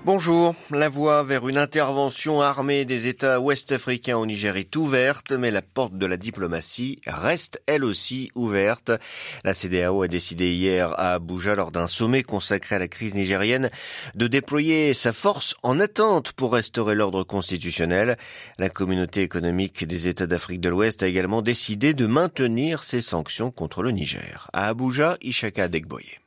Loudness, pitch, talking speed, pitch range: -23 LUFS, 115 Hz, 160 wpm, 95-135 Hz